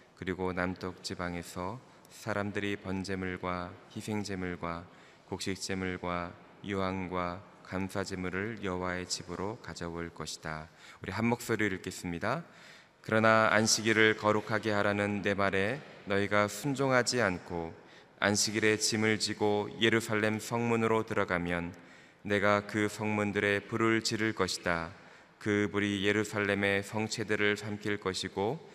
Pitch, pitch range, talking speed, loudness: 100 Hz, 90-110 Hz, 285 characters per minute, -31 LUFS